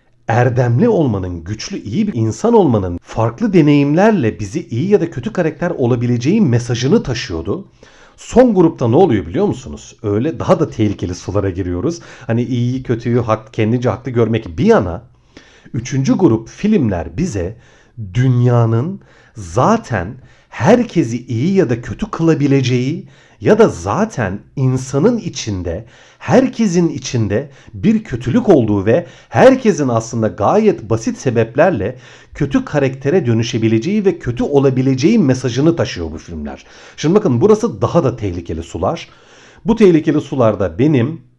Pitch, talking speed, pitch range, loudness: 125 Hz, 130 wpm, 115-165 Hz, -15 LUFS